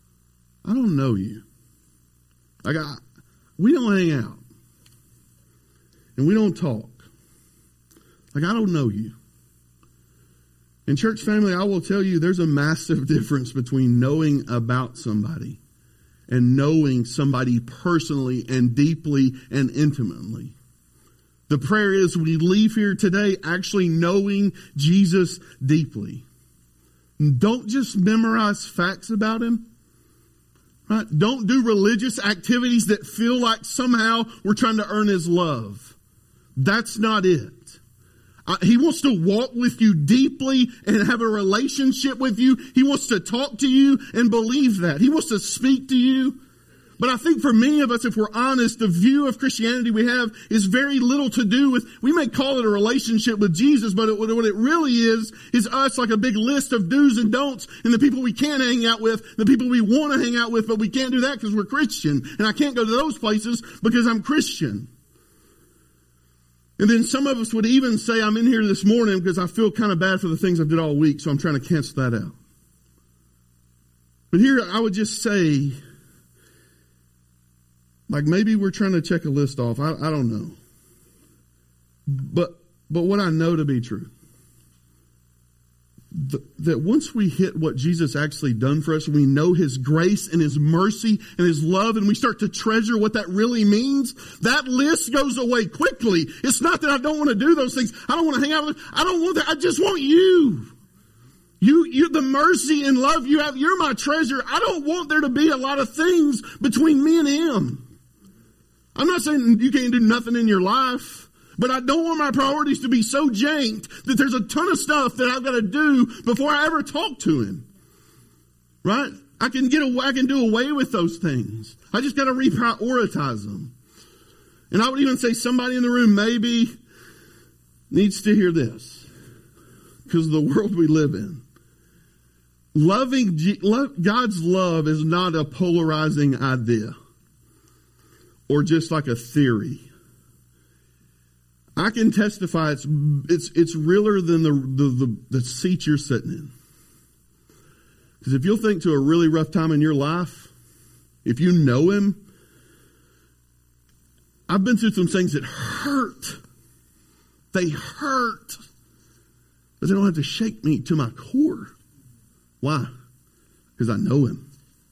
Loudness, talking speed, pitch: -20 LUFS, 175 wpm, 195 Hz